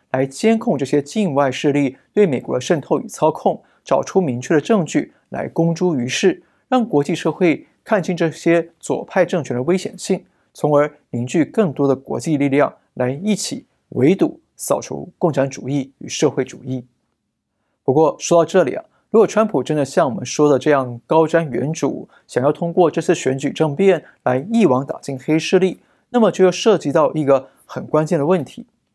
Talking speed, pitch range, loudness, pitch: 270 characters per minute, 135-185 Hz, -18 LUFS, 155 Hz